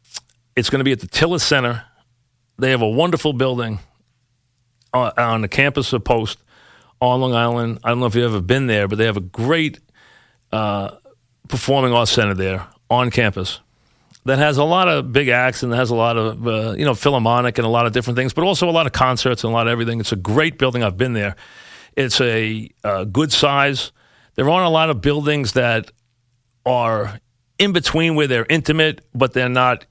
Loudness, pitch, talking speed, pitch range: -18 LUFS, 125 Hz, 205 wpm, 115-140 Hz